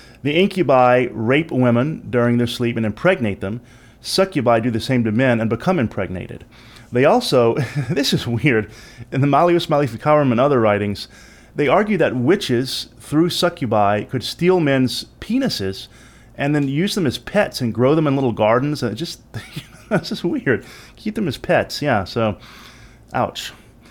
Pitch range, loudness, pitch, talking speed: 115-145 Hz, -18 LUFS, 125 Hz, 165 wpm